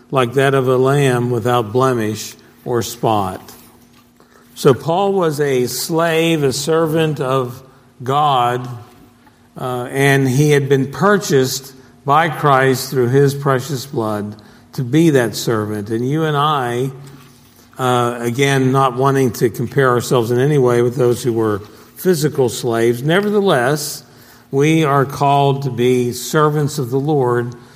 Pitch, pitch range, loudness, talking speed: 130 Hz, 120-140 Hz, -16 LUFS, 140 wpm